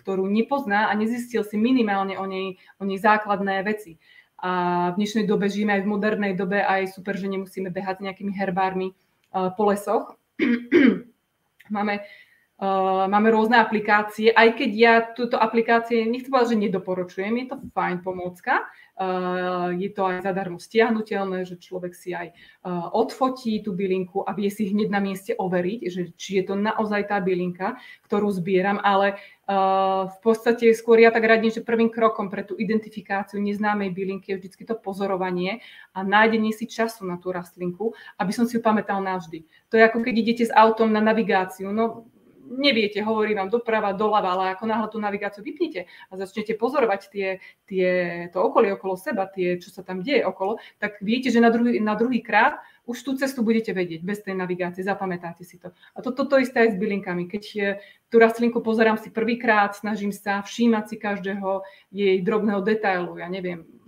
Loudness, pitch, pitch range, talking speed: -23 LUFS, 205 Hz, 190-225 Hz, 180 wpm